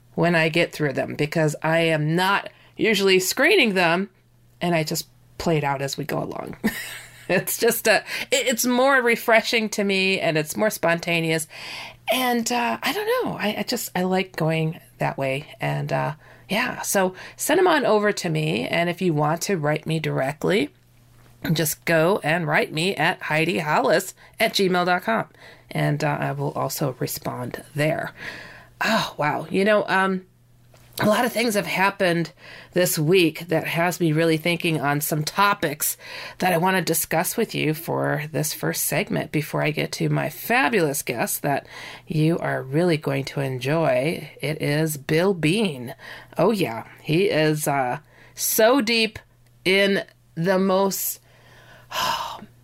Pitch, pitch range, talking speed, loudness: 165 Hz, 150-195 Hz, 165 wpm, -22 LUFS